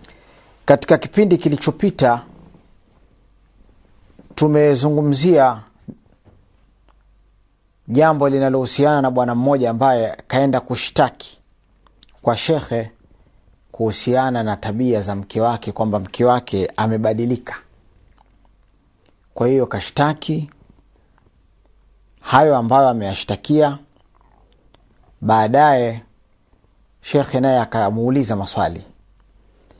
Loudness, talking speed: -17 LUFS, 70 wpm